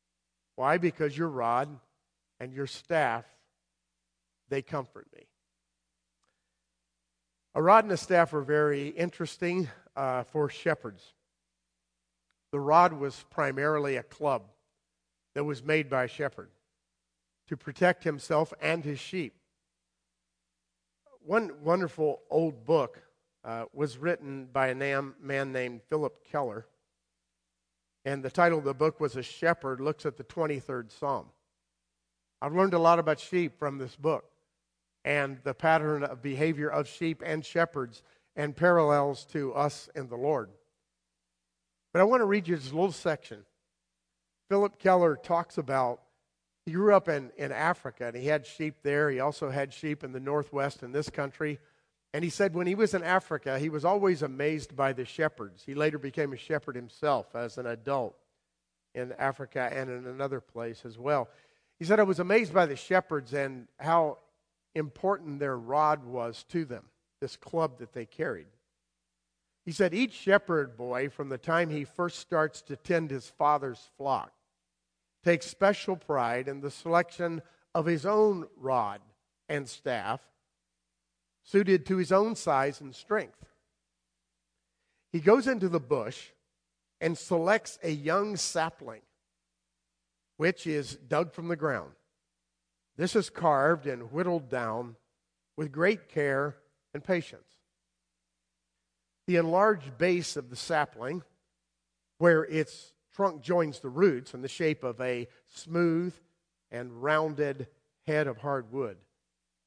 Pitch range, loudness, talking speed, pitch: 110-165 Hz, -30 LUFS, 145 wpm, 140 Hz